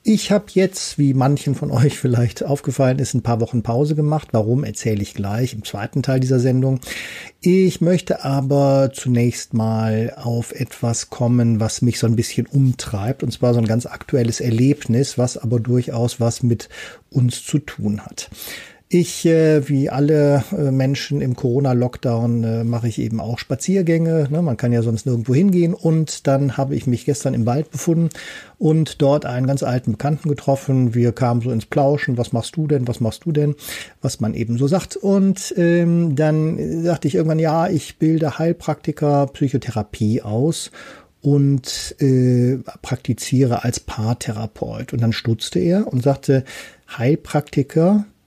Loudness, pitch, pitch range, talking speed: -19 LUFS, 135 Hz, 120-155 Hz, 160 wpm